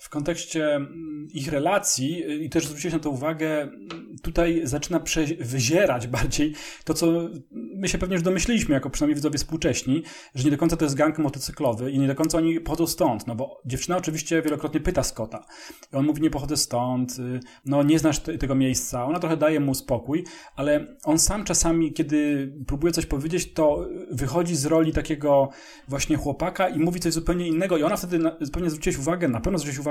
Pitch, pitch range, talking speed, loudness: 155 Hz, 140-165 Hz, 195 wpm, -24 LUFS